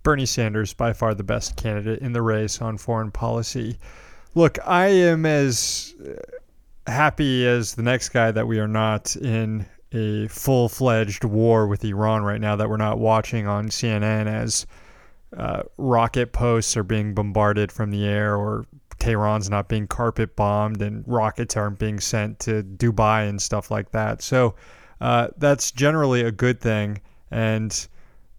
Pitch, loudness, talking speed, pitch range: 110 Hz, -22 LUFS, 160 wpm, 105-120 Hz